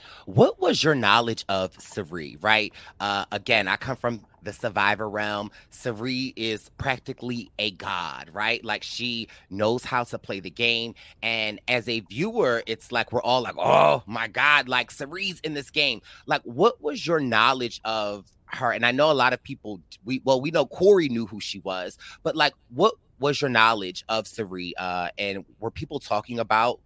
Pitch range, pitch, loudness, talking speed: 105-125 Hz, 115 Hz, -24 LUFS, 185 wpm